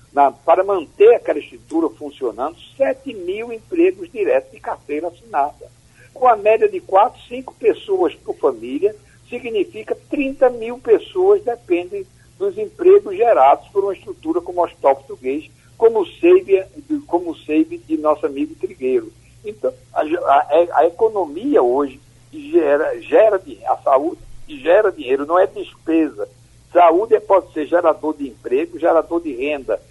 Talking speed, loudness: 140 wpm, -18 LUFS